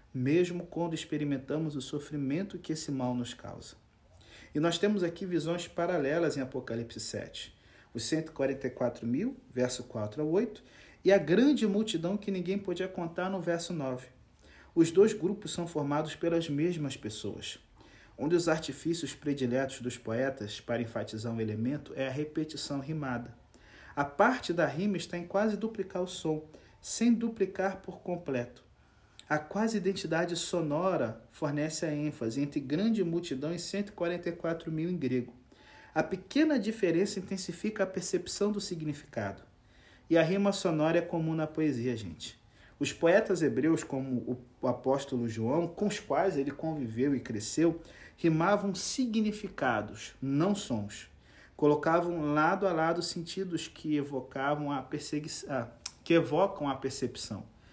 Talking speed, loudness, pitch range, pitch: 135 wpm, -32 LUFS, 130-180 Hz, 155 Hz